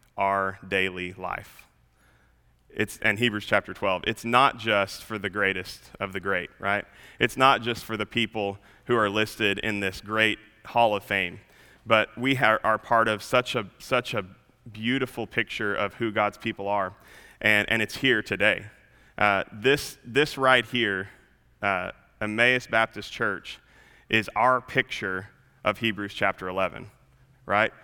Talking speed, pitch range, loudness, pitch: 155 wpm, 100-120 Hz, -25 LUFS, 110 Hz